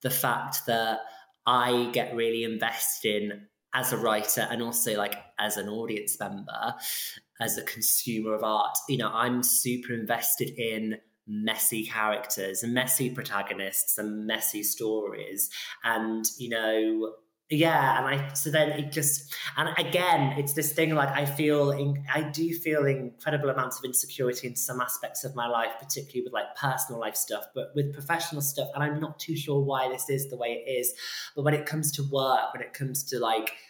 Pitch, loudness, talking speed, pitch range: 125 Hz, -28 LUFS, 180 wpm, 110-140 Hz